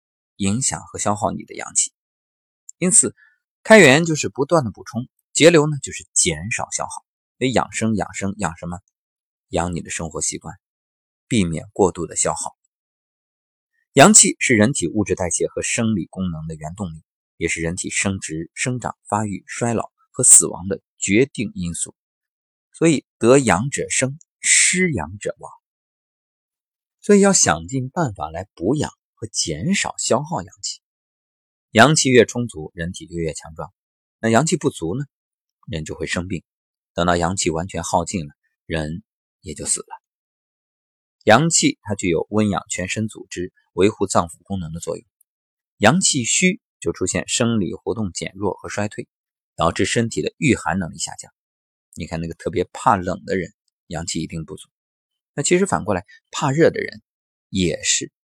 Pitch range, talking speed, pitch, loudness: 85-130 Hz, 235 characters per minute, 100 Hz, -19 LUFS